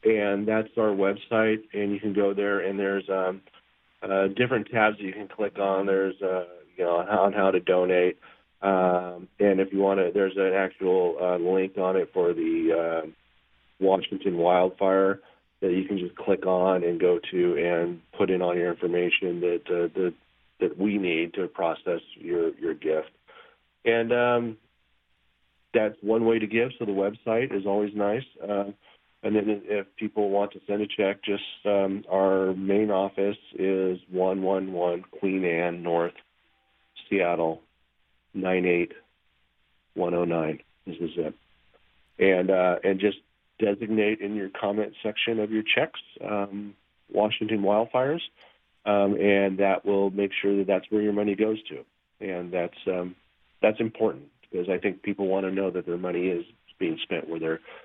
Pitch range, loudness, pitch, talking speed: 90-105 Hz, -26 LUFS, 95 Hz, 165 wpm